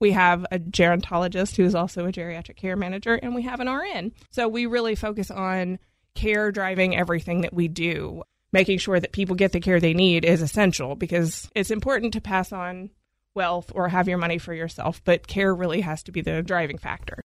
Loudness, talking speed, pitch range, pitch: -24 LUFS, 210 wpm, 175-200 Hz, 185 Hz